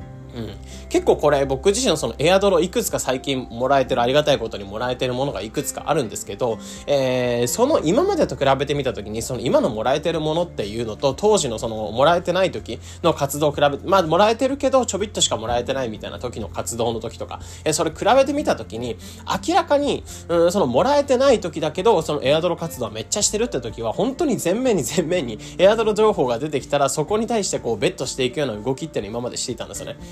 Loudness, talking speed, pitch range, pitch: -20 LUFS, 480 characters per minute, 120-195 Hz, 145 Hz